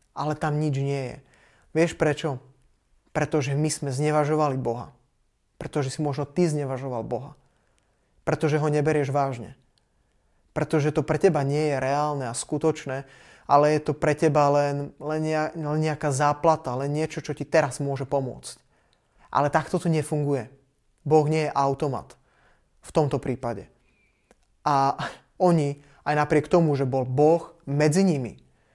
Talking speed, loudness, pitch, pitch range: 140 wpm, -25 LUFS, 150 Hz, 135-155 Hz